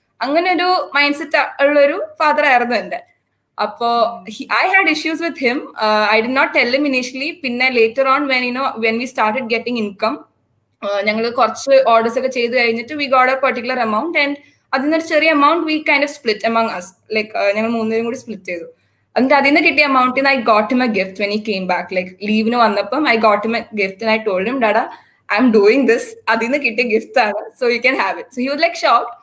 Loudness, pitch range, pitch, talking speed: -15 LUFS, 220-285 Hz, 245 Hz, 195 wpm